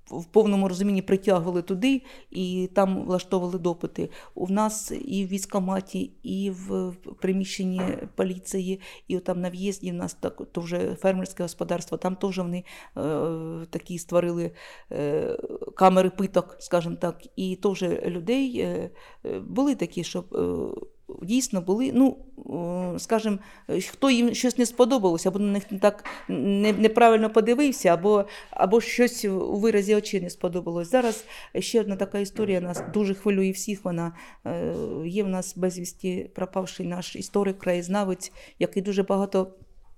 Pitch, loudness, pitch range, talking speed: 195 Hz, -26 LUFS, 180-215 Hz, 140 wpm